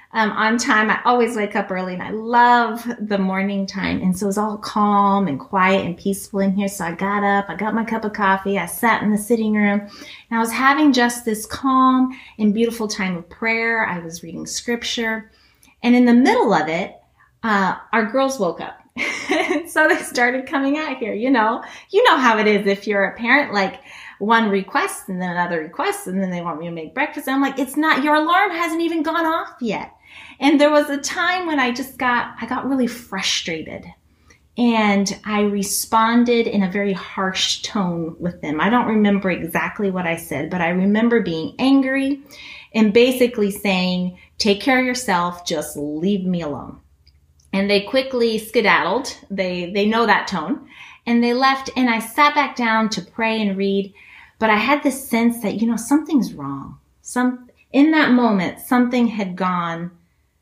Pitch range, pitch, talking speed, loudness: 195-255 Hz, 220 Hz, 195 wpm, -19 LUFS